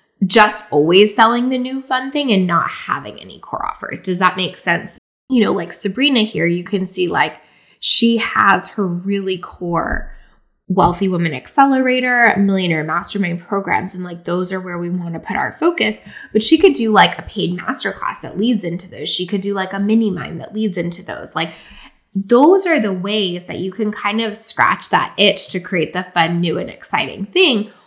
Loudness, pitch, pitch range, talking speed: -16 LUFS, 200 Hz, 180-225 Hz, 200 wpm